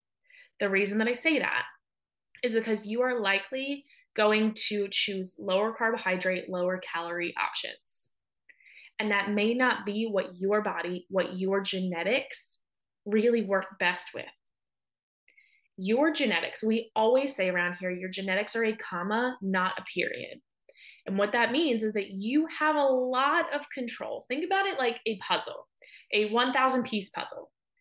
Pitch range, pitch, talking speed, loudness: 190-255 Hz, 215 Hz, 155 wpm, -28 LUFS